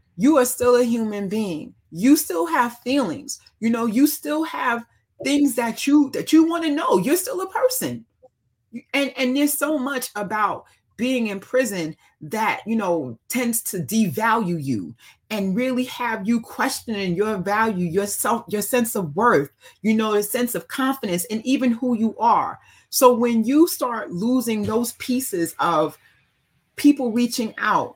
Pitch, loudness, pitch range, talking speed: 240 Hz, -21 LUFS, 215-270 Hz, 165 wpm